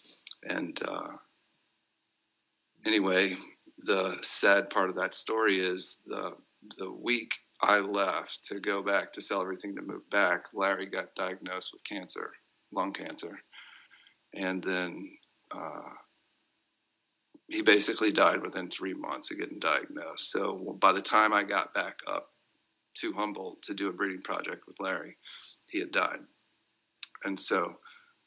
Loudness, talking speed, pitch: -29 LUFS, 140 wpm, 310 Hz